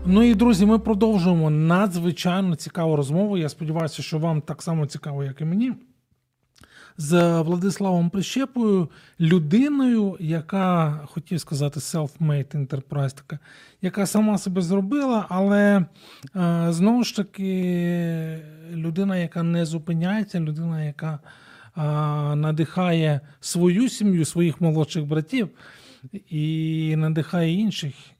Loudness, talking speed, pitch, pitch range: -23 LUFS, 105 wpm, 170 Hz, 155-190 Hz